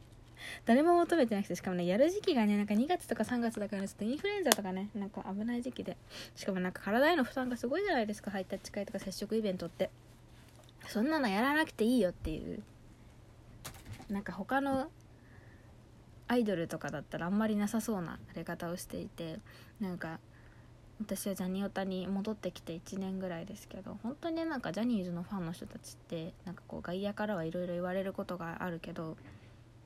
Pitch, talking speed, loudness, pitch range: 190 Hz, 420 characters per minute, -35 LUFS, 165-220 Hz